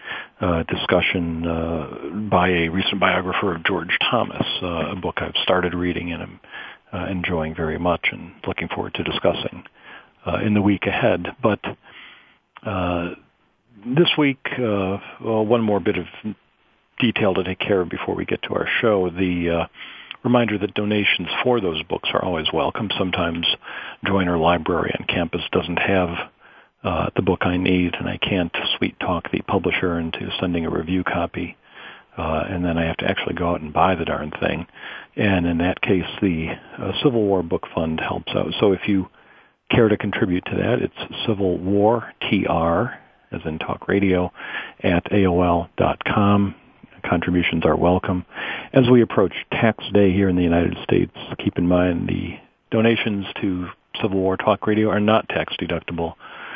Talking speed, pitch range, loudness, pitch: 170 wpm, 85-105 Hz, -21 LUFS, 95 Hz